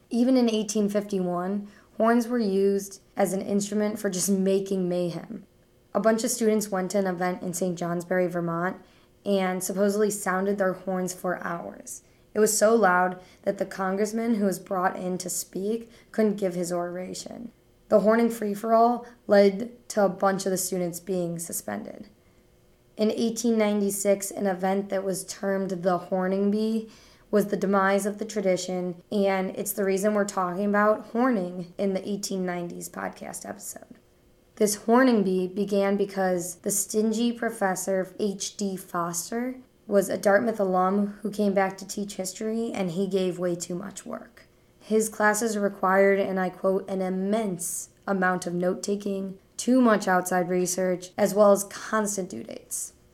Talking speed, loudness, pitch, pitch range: 160 wpm, -26 LUFS, 195 Hz, 185-210 Hz